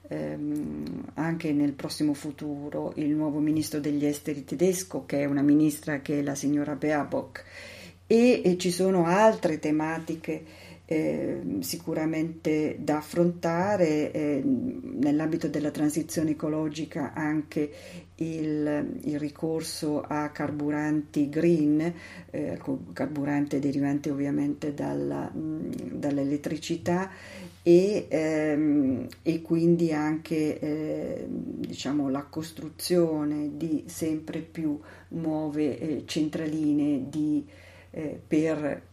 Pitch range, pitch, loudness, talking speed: 145-160 Hz, 150 Hz, -28 LUFS, 100 wpm